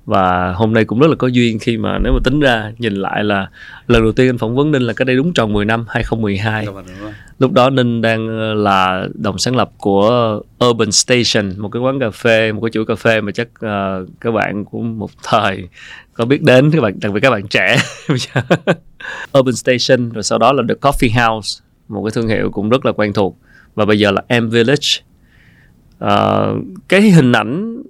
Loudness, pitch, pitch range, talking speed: -14 LUFS, 115 Hz, 105-130 Hz, 215 wpm